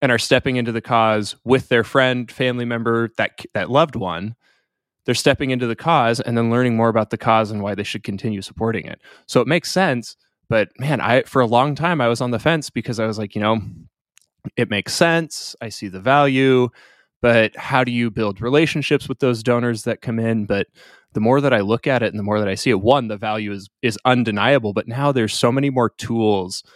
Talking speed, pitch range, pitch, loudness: 230 wpm, 110-130 Hz, 120 Hz, -19 LUFS